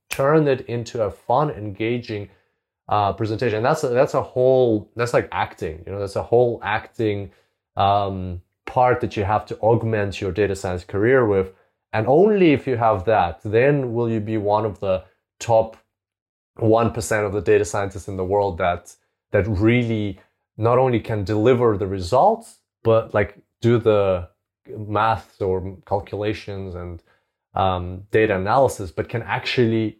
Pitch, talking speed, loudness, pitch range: 105 Hz, 160 wpm, -21 LUFS, 100-115 Hz